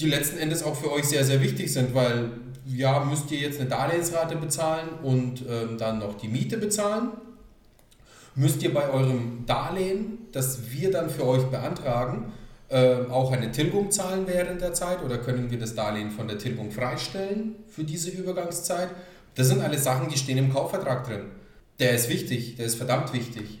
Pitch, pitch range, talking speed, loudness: 135 Hz, 120-170 Hz, 185 wpm, -27 LUFS